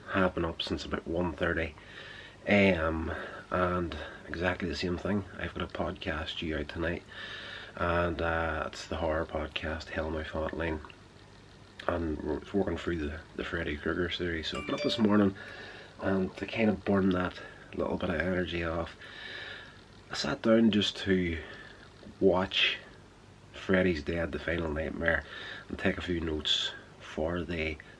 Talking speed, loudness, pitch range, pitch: 160 wpm, -31 LUFS, 80-95 Hz, 85 Hz